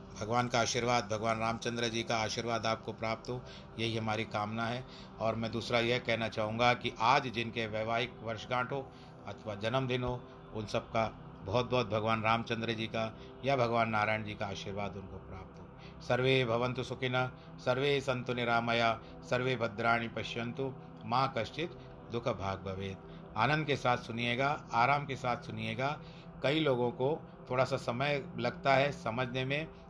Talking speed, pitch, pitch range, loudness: 160 wpm, 120 Hz, 110-130 Hz, -33 LUFS